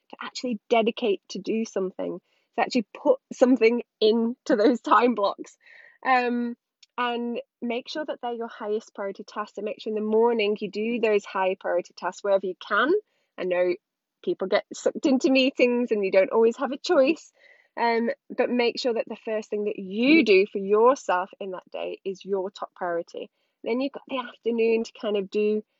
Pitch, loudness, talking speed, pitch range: 230 Hz, -25 LUFS, 190 wpm, 210-260 Hz